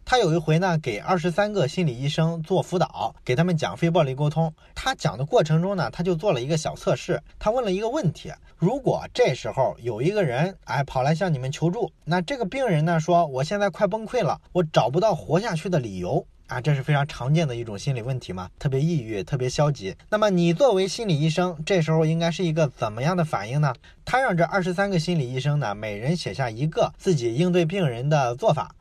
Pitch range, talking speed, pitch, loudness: 140-180 Hz, 340 characters per minute, 165 Hz, -24 LUFS